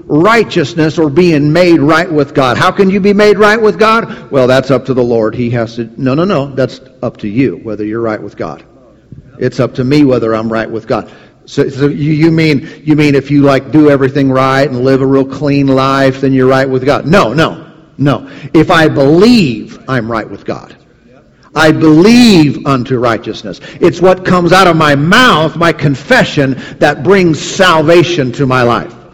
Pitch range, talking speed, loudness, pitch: 130-165 Hz, 200 wpm, -9 LUFS, 140 Hz